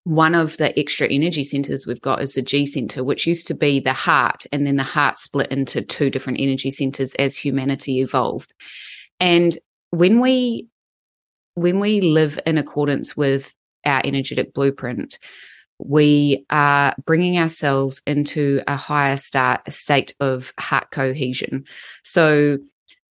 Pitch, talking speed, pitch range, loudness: 140 Hz, 150 wpm, 135-155 Hz, -19 LUFS